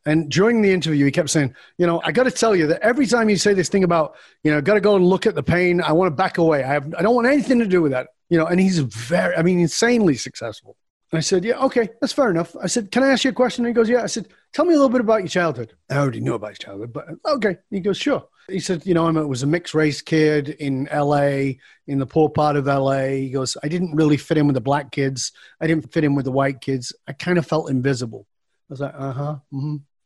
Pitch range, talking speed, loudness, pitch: 140-200 Hz, 295 wpm, -19 LUFS, 165 Hz